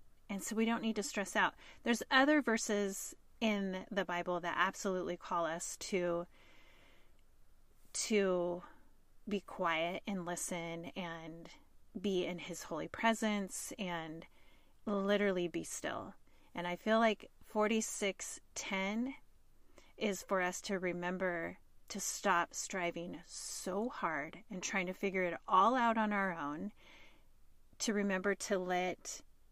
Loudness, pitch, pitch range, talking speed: -37 LUFS, 190 Hz, 175-215 Hz, 130 wpm